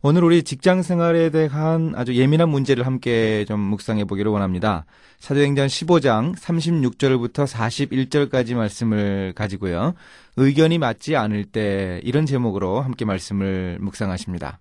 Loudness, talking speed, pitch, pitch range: -20 LUFS, 310 characters per minute, 125 Hz, 100-145 Hz